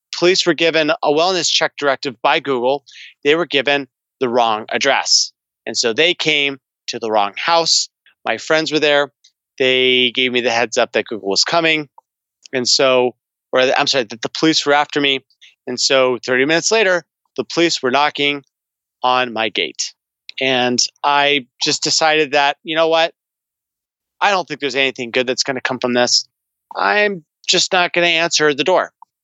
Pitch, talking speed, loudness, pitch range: 140 Hz, 180 wpm, -16 LUFS, 125-160 Hz